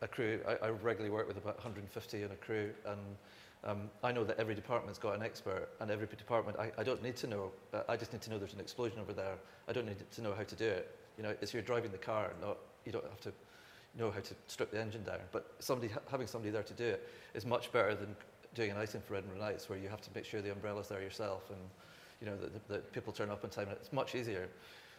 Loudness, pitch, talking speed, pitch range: -42 LUFS, 105 Hz, 270 wpm, 100-115 Hz